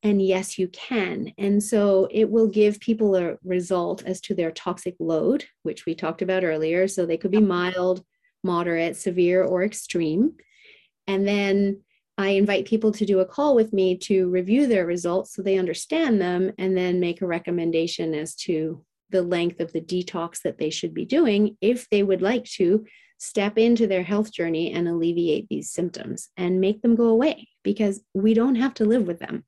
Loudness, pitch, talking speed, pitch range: -23 LUFS, 190 Hz, 190 wpm, 180-215 Hz